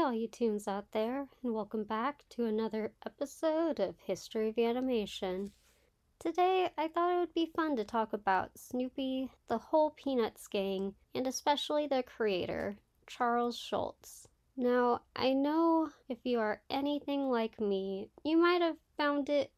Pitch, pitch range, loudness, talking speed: 245 Hz, 220-290 Hz, -34 LUFS, 155 wpm